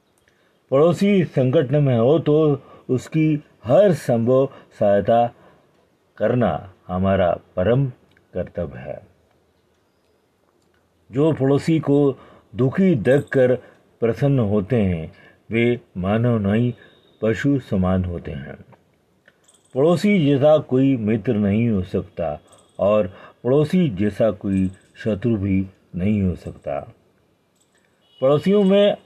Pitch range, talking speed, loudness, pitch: 95-140 Hz, 100 wpm, -20 LUFS, 120 Hz